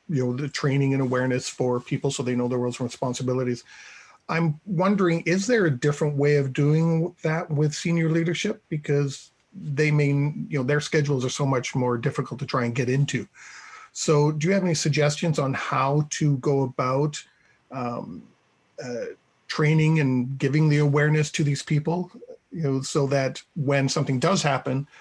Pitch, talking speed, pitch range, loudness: 145 Hz, 180 wpm, 135-160 Hz, -24 LUFS